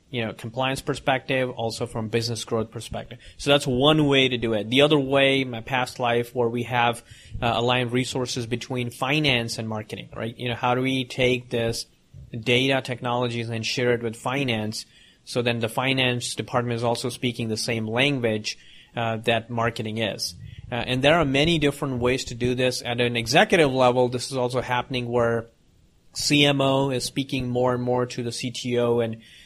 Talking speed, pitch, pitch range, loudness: 185 wpm, 125 Hz, 115-130 Hz, -23 LUFS